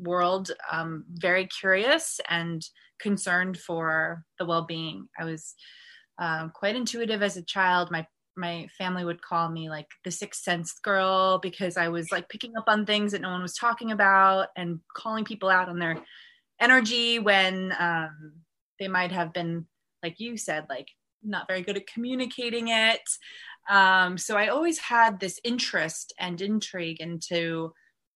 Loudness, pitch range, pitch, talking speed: -26 LUFS, 170-215 Hz, 185 Hz, 160 wpm